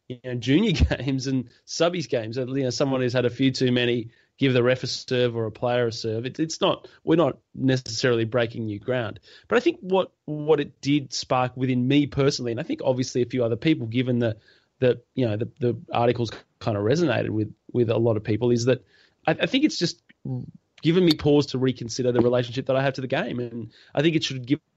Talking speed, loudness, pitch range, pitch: 235 wpm, -24 LUFS, 120-140 Hz, 125 Hz